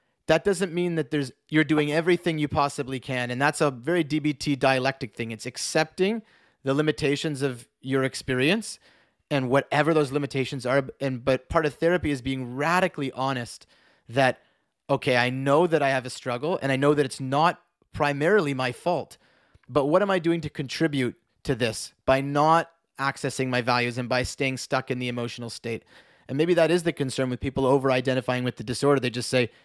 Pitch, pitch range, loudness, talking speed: 140 Hz, 130-155 Hz, -25 LUFS, 190 wpm